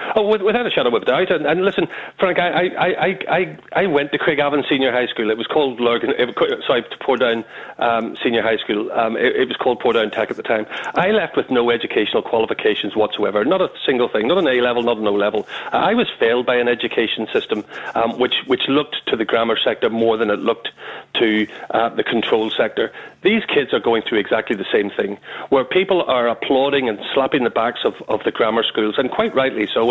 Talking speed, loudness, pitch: 230 wpm, -18 LUFS, 135 Hz